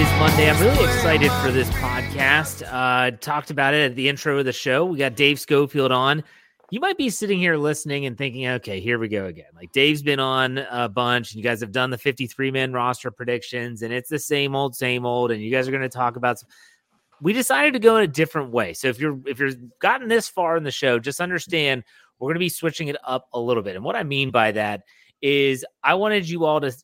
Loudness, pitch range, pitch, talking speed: -21 LUFS, 125-150 Hz, 135 Hz, 240 wpm